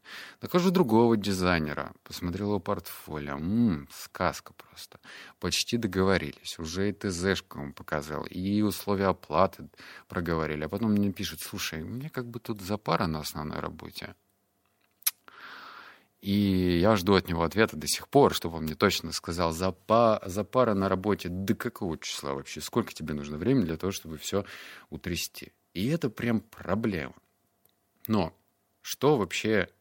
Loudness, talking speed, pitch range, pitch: -29 LUFS, 145 wpm, 80-105 Hz, 95 Hz